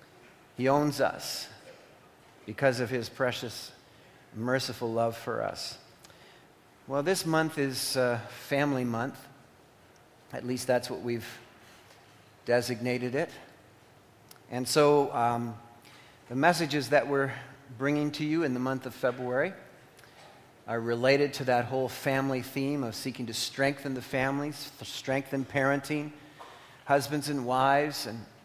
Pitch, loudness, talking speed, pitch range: 130 Hz, -30 LUFS, 125 wpm, 120-140 Hz